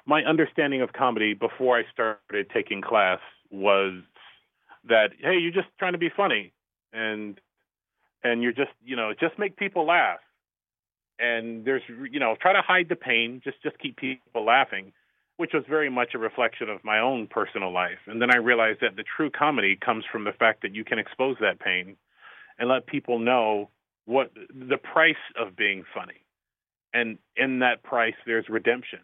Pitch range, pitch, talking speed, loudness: 115-155 Hz, 125 Hz, 180 wpm, -25 LUFS